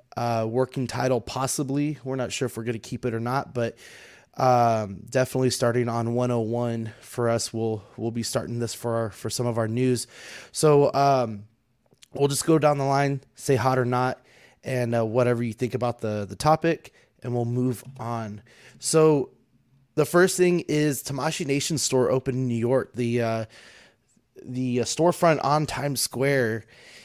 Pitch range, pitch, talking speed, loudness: 115-135 Hz, 125 Hz, 175 wpm, -25 LUFS